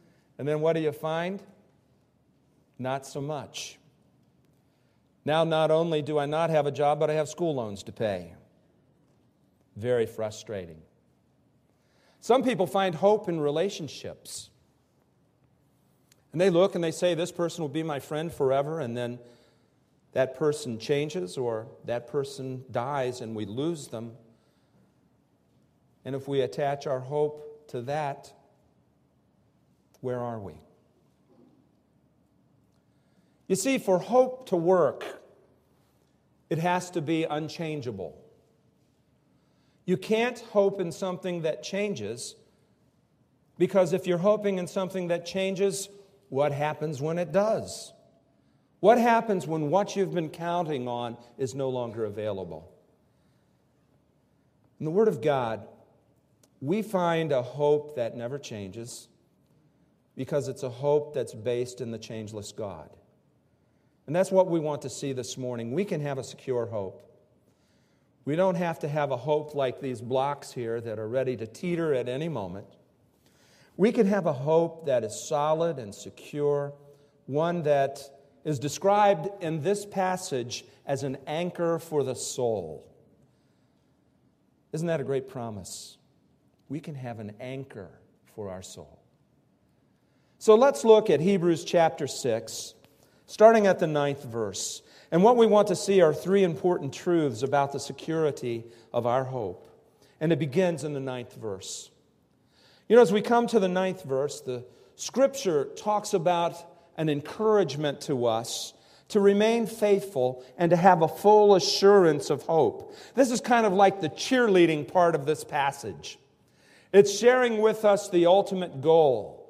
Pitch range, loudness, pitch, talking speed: 130-185 Hz, -26 LUFS, 155 Hz, 145 wpm